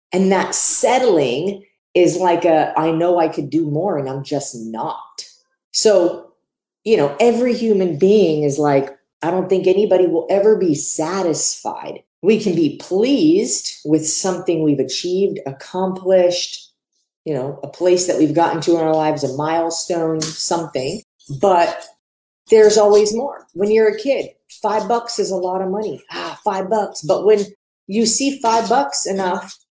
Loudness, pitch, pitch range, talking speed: -17 LUFS, 185 Hz, 160-210 Hz, 160 wpm